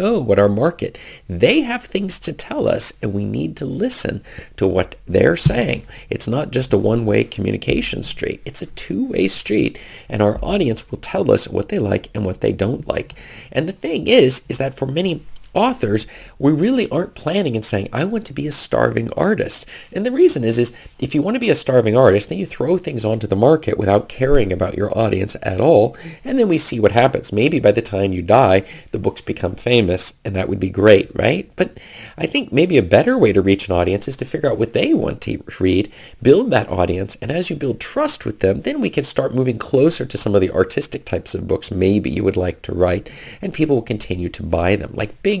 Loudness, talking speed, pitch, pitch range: -18 LUFS, 230 wpm, 115 Hz, 100-155 Hz